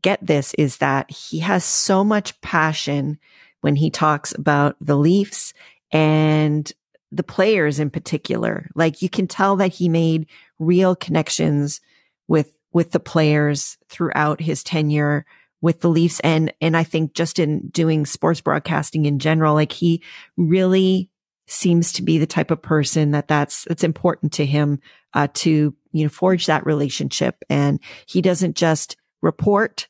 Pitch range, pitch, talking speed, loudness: 150-175 Hz, 160 Hz, 155 wpm, -19 LUFS